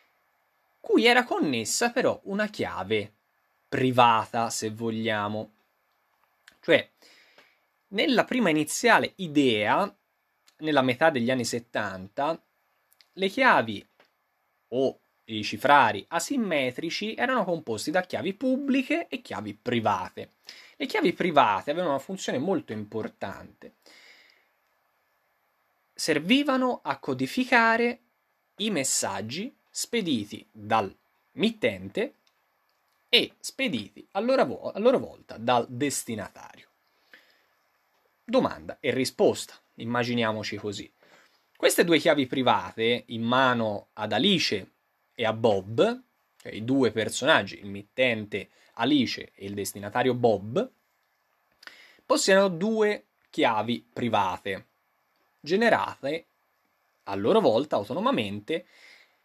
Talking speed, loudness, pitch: 95 wpm, -26 LUFS, 135 Hz